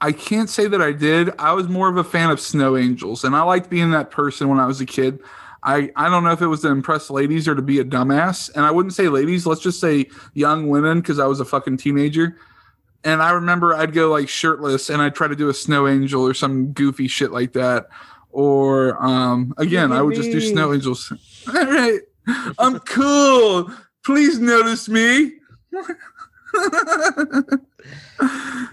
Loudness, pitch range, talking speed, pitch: -18 LUFS, 140-210 Hz, 195 wpm, 155 Hz